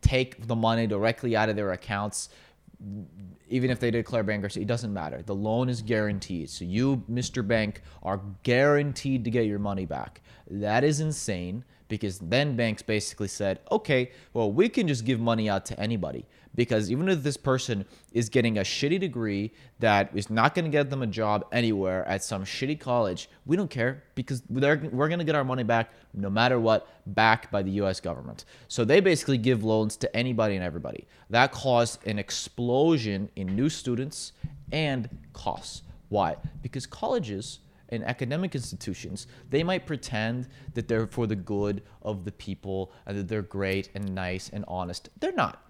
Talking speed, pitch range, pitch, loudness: 180 wpm, 100-130 Hz, 115 Hz, -28 LUFS